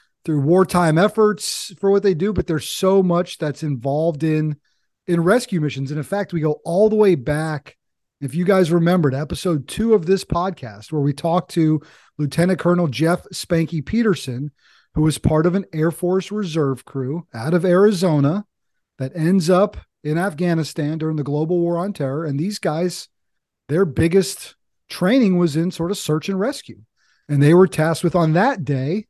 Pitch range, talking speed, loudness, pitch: 150-190 Hz, 180 wpm, -19 LUFS, 170 Hz